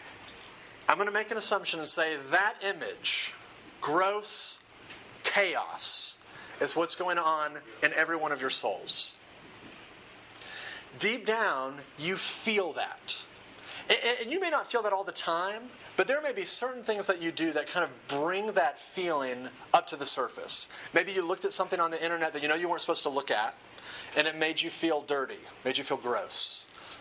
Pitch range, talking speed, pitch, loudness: 150-200 Hz, 180 wpm, 170 Hz, -30 LUFS